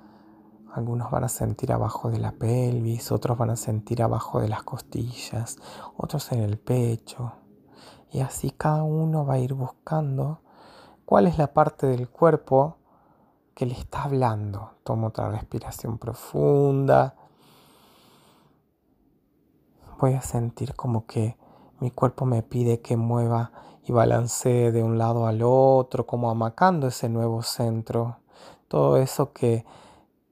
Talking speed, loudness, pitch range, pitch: 135 wpm, -25 LUFS, 115-130 Hz, 120 Hz